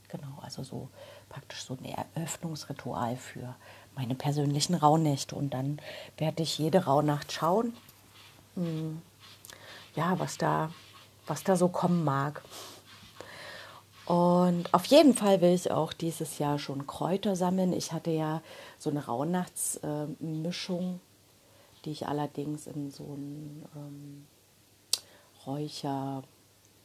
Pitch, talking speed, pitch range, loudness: 145 Hz, 115 wpm, 125-165 Hz, -30 LUFS